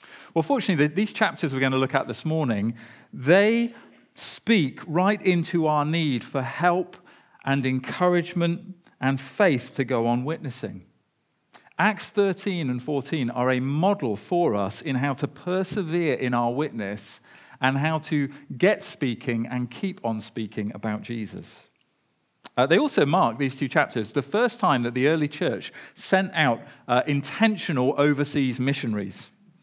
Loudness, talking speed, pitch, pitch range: -24 LUFS, 150 wpm, 145 Hz, 125-180 Hz